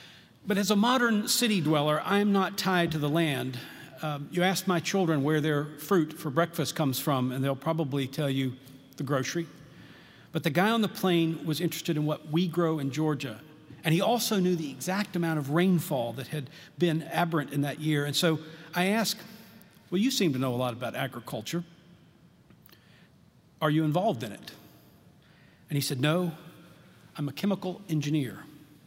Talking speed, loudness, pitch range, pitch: 180 wpm, -28 LUFS, 150-180 Hz, 160 Hz